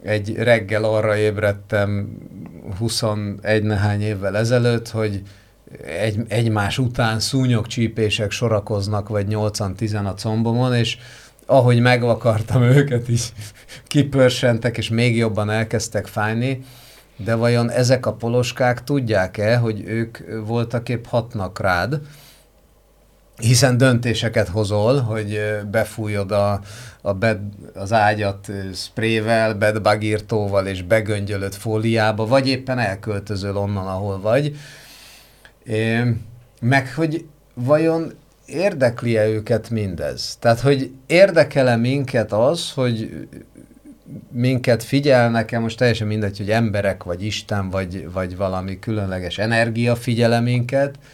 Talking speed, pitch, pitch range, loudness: 105 wpm, 110 Hz, 105-120 Hz, -20 LUFS